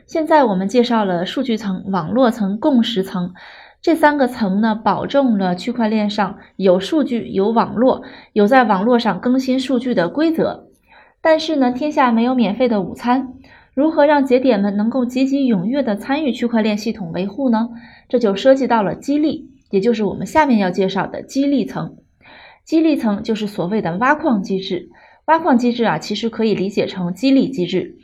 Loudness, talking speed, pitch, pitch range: -17 LUFS, 280 characters per minute, 235 Hz, 205-270 Hz